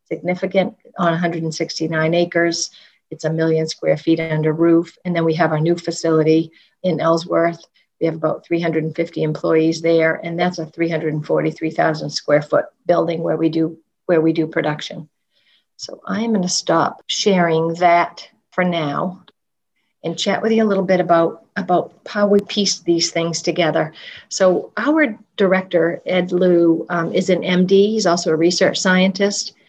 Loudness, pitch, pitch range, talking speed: -18 LUFS, 170 Hz, 160-185 Hz, 160 wpm